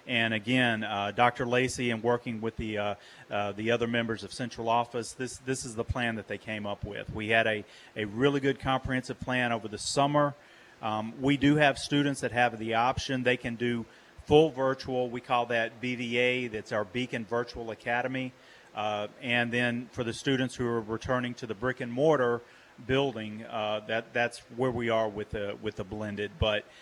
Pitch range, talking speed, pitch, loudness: 110-130 Hz, 195 wpm, 120 Hz, -30 LUFS